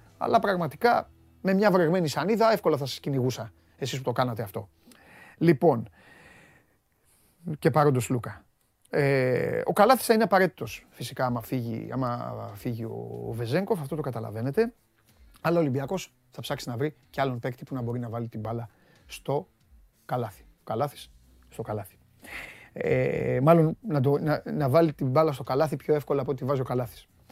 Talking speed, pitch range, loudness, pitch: 155 wpm, 120-160 Hz, -27 LUFS, 135 Hz